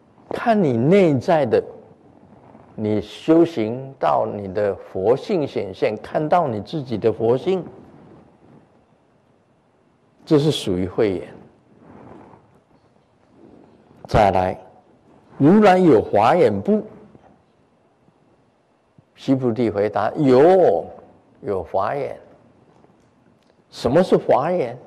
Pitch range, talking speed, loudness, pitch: 110-180 Hz, 125 characters per minute, -19 LUFS, 135 Hz